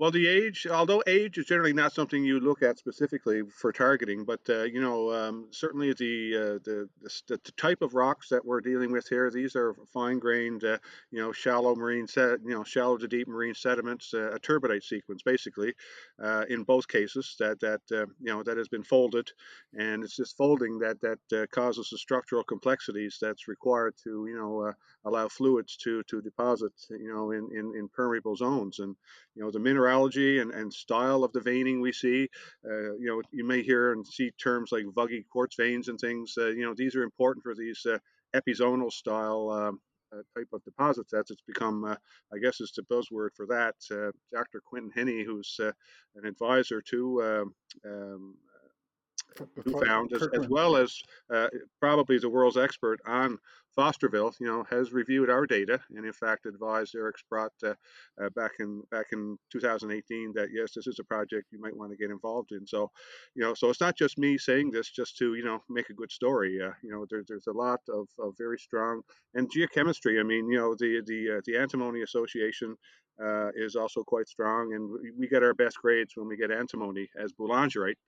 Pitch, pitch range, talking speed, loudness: 115 Hz, 110-125 Hz, 205 wpm, -30 LUFS